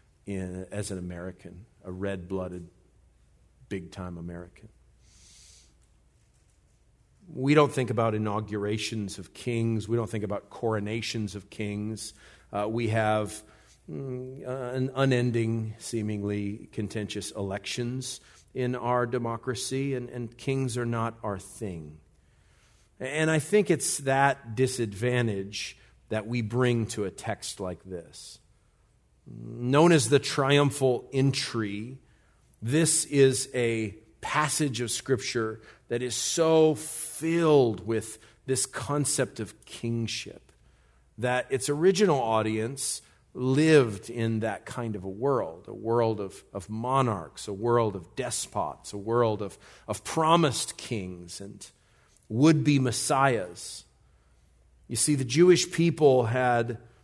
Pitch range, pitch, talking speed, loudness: 105-130 Hz, 115 Hz, 120 wpm, -27 LUFS